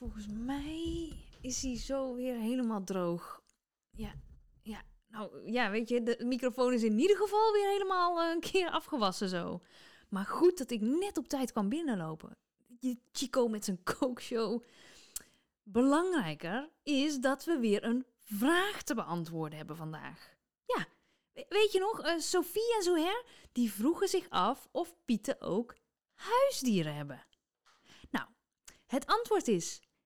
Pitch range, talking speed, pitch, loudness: 220-330 Hz, 145 wpm, 255 Hz, -33 LUFS